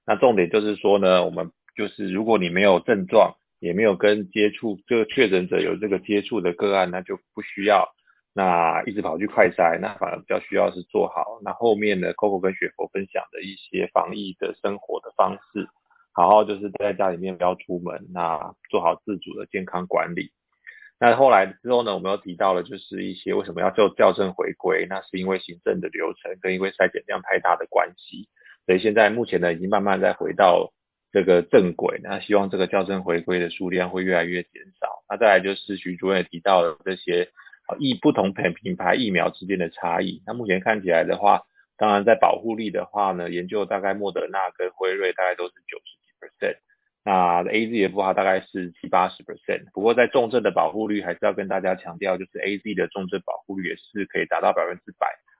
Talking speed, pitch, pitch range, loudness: 335 characters per minute, 95 Hz, 90-105 Hz, -22 LUFS